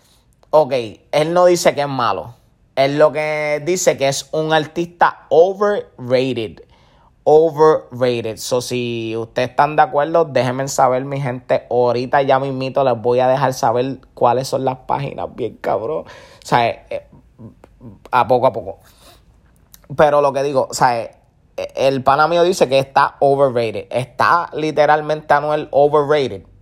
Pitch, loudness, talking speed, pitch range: 135 Hz, -16 LUFS, 150 wpm, 125-155 Hz